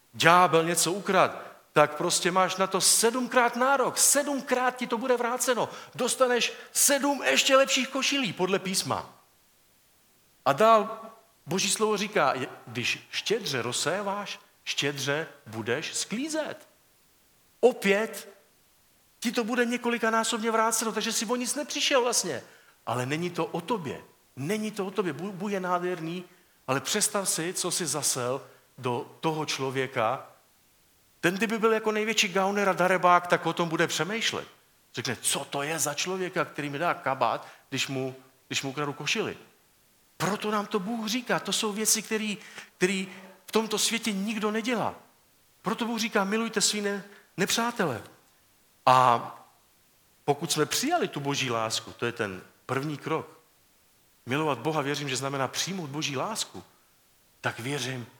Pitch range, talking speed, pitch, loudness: 150-225 Hz, 145 wpm, 190 Hz, -27 LUFS